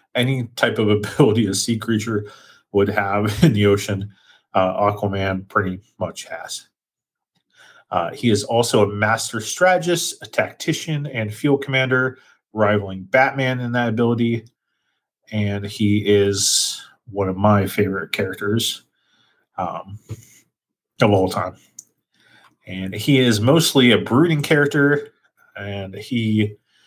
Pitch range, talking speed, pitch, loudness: 100-130 Hz, 125 wpm, 110 Hz, -19 LUFS